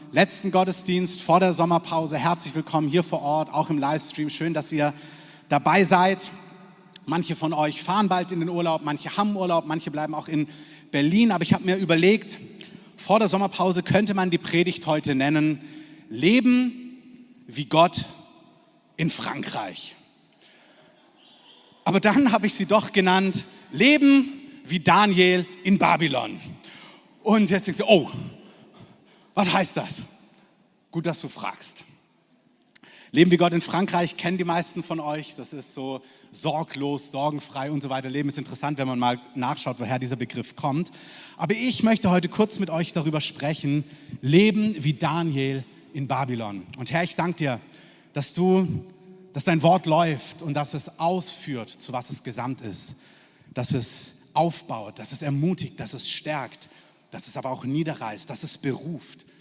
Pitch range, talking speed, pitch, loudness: 145-185 Hz, 160 wpm, 165 Hz, -24 LUFS